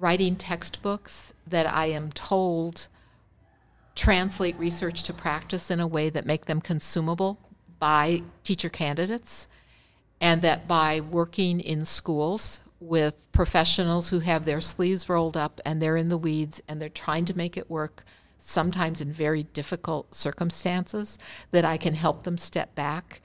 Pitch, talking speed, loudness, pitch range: 165 Hz, 150 wpm, -27 LUFS, 155-175 Hz